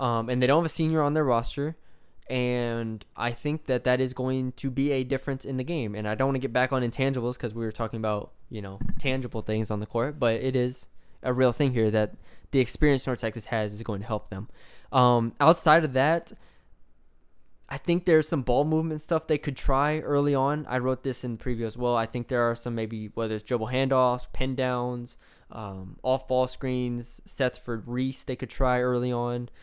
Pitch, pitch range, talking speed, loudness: 125 Hz, 115-135 Hz, 225 wpm, -27 LUFS